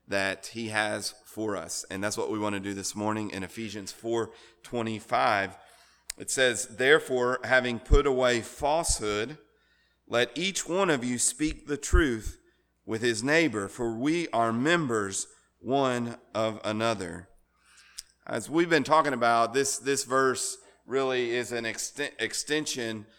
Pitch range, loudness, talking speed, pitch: 105-135 Hz, -28 LUFS, 145 wpm, 115 Hz